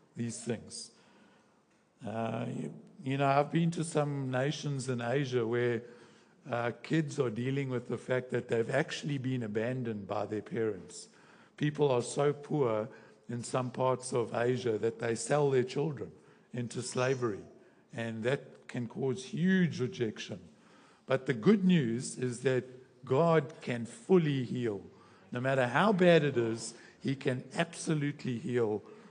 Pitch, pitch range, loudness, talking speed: 130 Hz, 120-145 Hz, -32 LUFS, 145 wpm